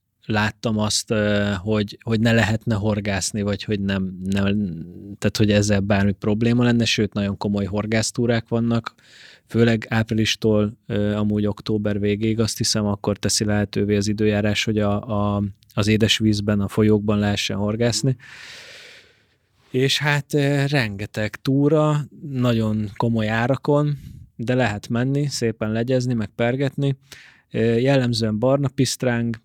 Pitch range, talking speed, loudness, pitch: 105-120 Hz, 120 wpm, -21 LUFS, 110 Hz